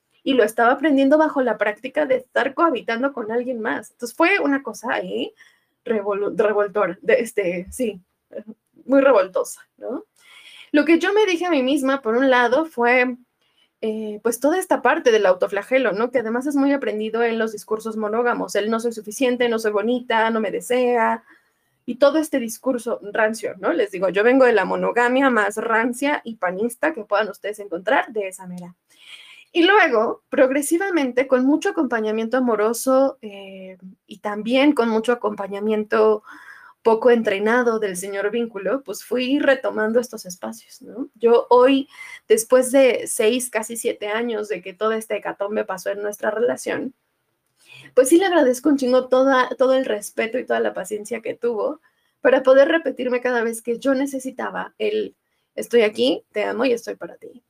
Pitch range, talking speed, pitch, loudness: 215-275 Hz, 170 wpm, 240 Hz, -20 LUFS